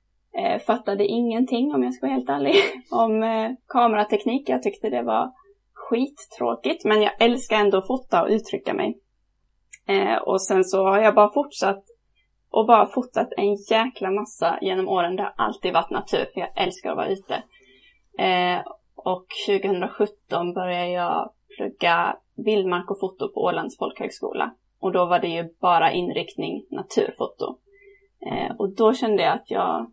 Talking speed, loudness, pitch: 150 wpm, -23 LUFS, 220 Hz